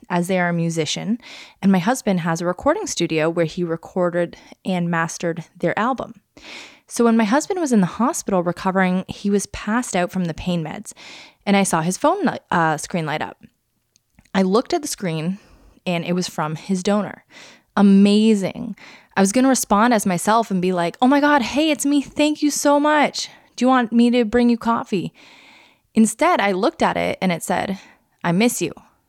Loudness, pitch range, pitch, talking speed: -19 LUFS, 180-250 Hz, 205 Hz, 200 wpm